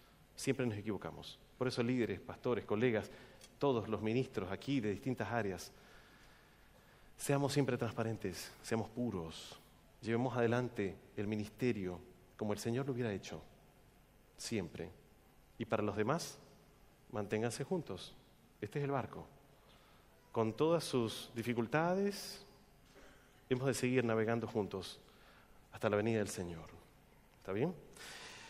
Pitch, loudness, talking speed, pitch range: 115 Hz, -39 LUFS, 120 wpm, 105-130 Hz